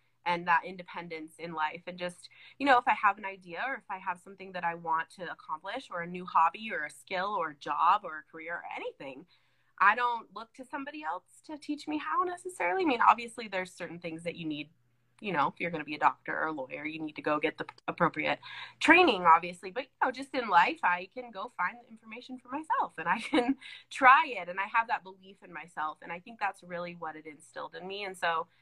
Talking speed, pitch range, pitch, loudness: 245 wpm, 165-245 Hz, 180 Hz, -30 LUFS